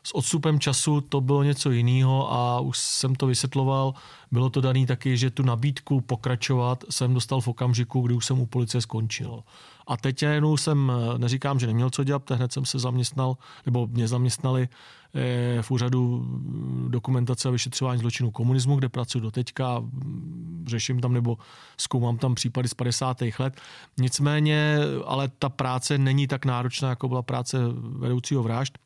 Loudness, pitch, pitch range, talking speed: -25 LUFS, 130 Hz, 125-135 Hz, 160 wpm